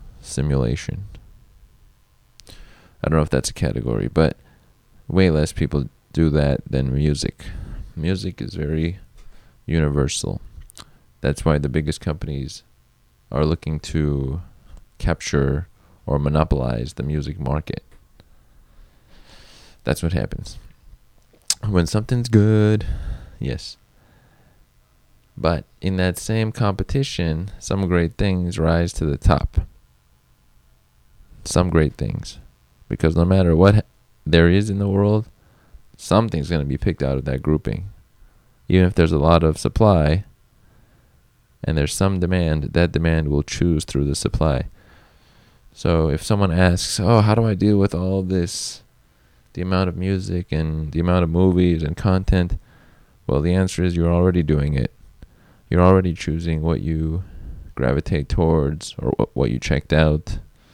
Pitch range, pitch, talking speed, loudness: 70-95 Hz, 80 Hz, 135 wpm, -20 LUFS